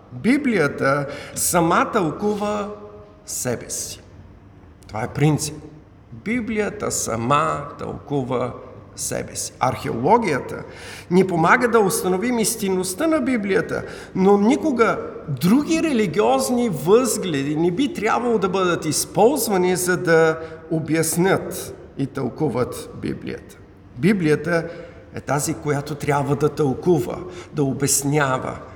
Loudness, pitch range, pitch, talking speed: -20 LUFS, 140-210 Hz, 160 Hz, 100 wpm